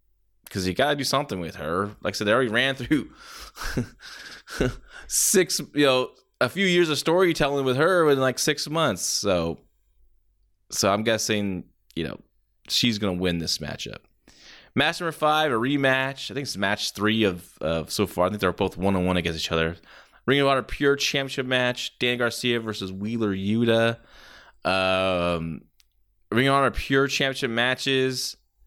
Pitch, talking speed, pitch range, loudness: 120 Hz, 175 wpm, 95-135 Hz, -24 LUFS